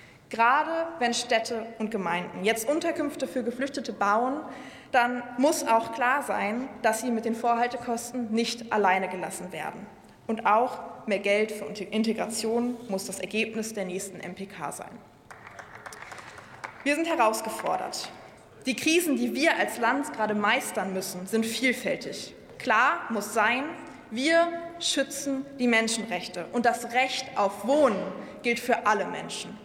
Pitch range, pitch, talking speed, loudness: 215-260 Hz, 235 Hz, 135 wpm, -27 LUFS